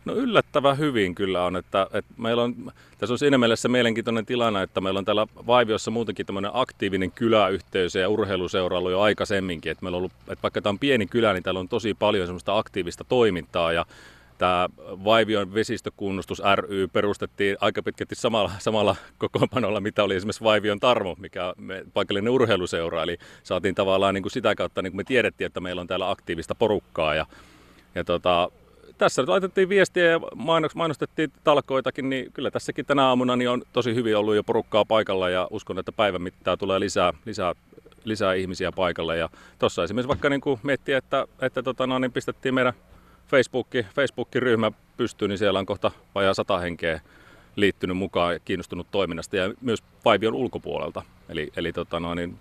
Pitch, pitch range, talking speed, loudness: 110 Hz, 95-130 Hz, 175 wpm, -24 LUFS